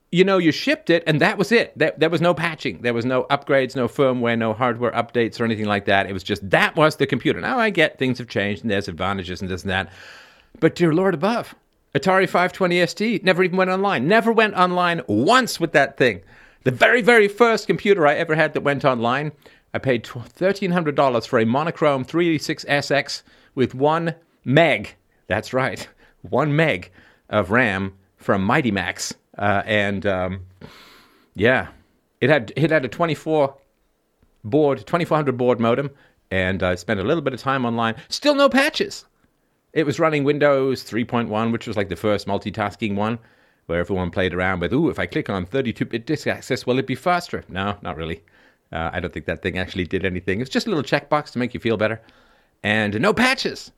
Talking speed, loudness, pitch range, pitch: 195 wpm, -20 LUFS, 105-170 Hz, 130 Hz